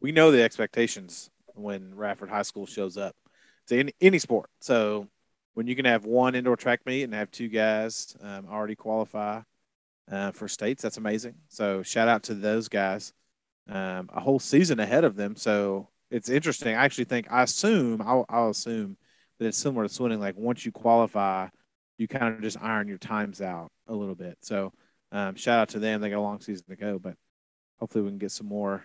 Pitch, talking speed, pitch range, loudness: 110 Hz, 205 wpm, 100-120 Hz, -27 LUFS